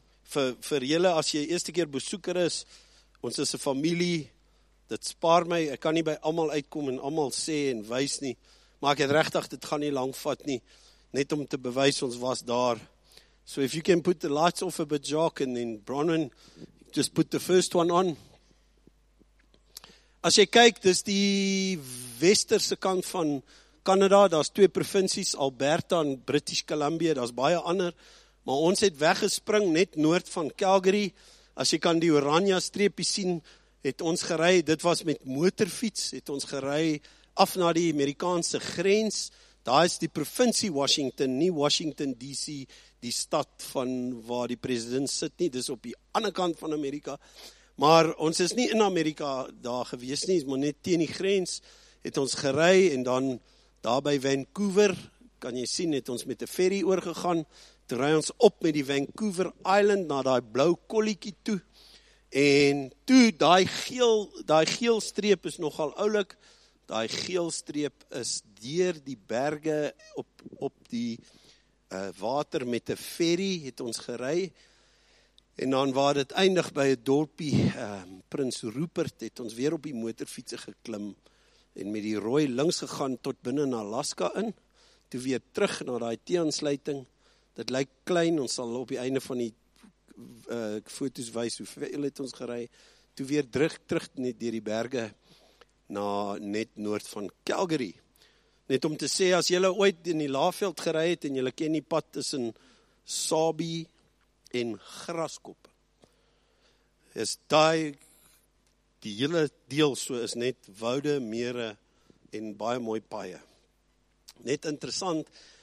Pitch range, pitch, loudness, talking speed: 130-175 Hz, 150 Hz, -28 LUFS, 165 wpm